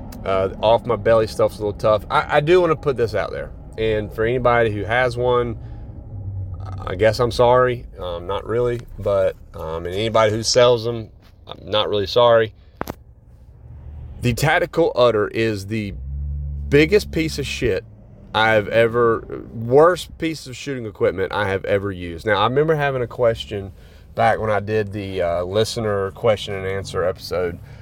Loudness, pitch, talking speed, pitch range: -19 LUFS, 110 Hz, 170 wpm, 100-120 Hz